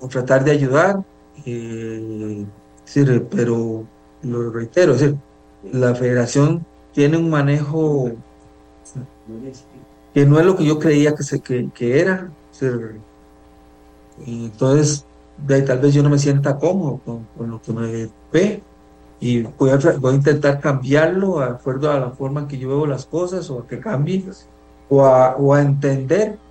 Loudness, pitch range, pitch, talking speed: -18 LUFS, 115-145 Hz, 130 Hz, 155 wpm